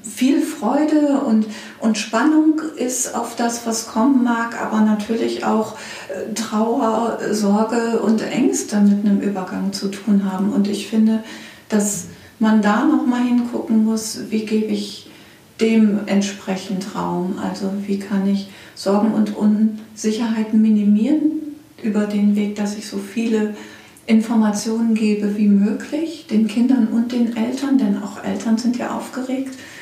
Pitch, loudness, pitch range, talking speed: 220 Hz, -19 LUFS, 210-235 Hz, 140 wpm